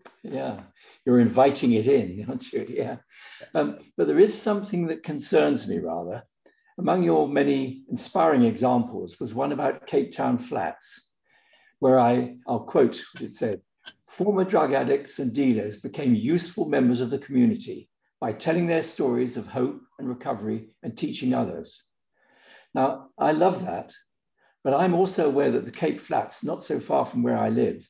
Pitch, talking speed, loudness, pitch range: 150 Hz, 160 wpm, -25 LUFS, 125-200 Hz